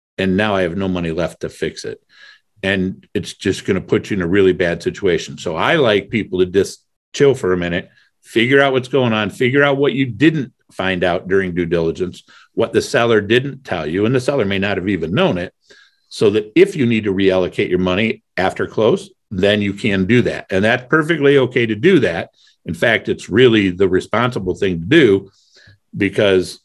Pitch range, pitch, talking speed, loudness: 95-135 Hz, 105 Hz, 215 wpm, -16 LUFS